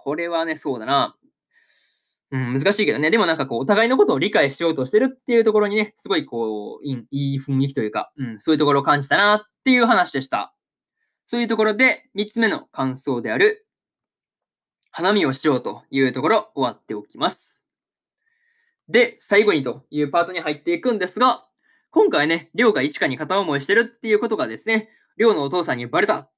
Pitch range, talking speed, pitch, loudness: 140-230 Hz, 400 characters per minute, 200 Hz, -20 LUFS